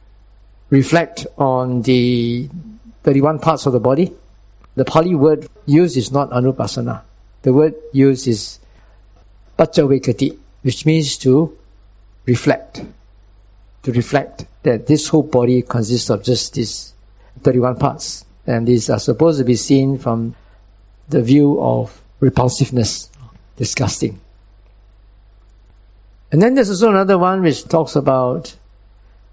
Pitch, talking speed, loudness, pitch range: 125 Hz, 120 wpm, -16 LUFS, 100-145 Hz